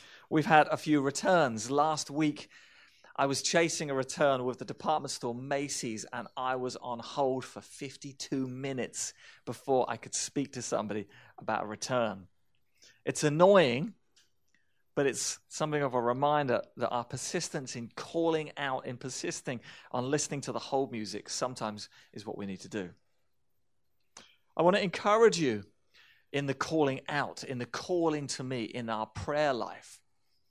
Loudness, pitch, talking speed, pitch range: -31 LUFS, 135 Hz, 160 wpm, 120-150 Hz